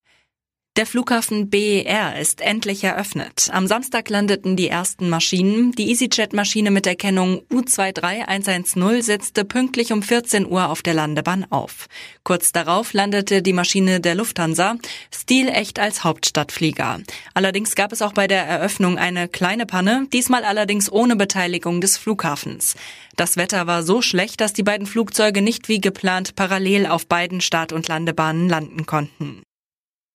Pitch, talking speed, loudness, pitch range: 195 Hz, 145 wpm, -19 LUFS, 175-215 Hz